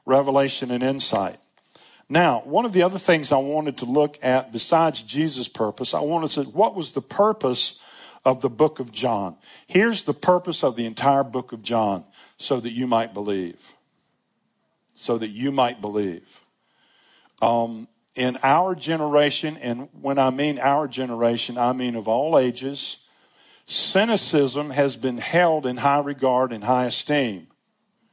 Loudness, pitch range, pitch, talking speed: -22 LUFS, 120-150 Hz, 135 Hz, 160 wpm